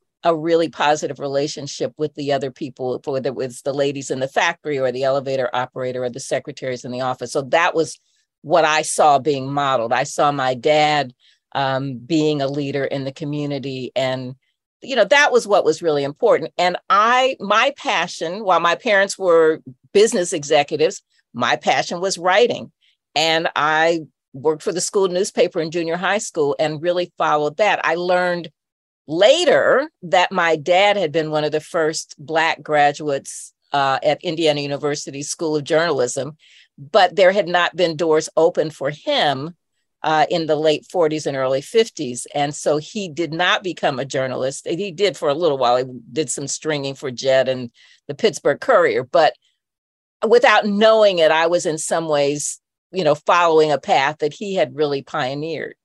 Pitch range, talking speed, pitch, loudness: 140-175 Hz, 175 wpm, 155 Hz, -19 LUFS